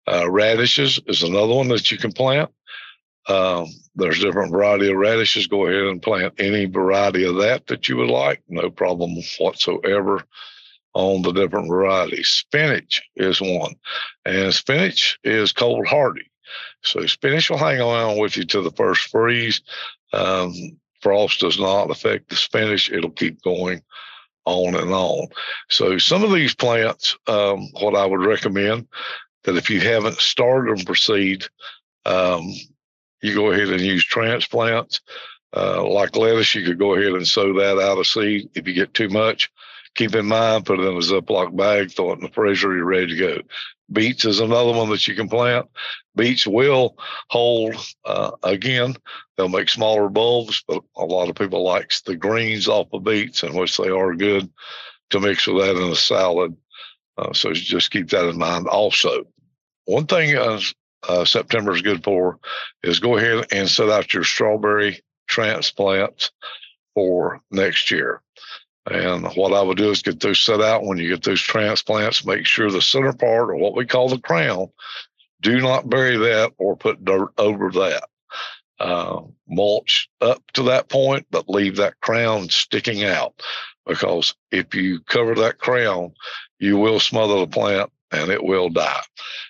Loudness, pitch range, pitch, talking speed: -19 LUFS, 95-115 Hz, 100 Hz, 170 wpm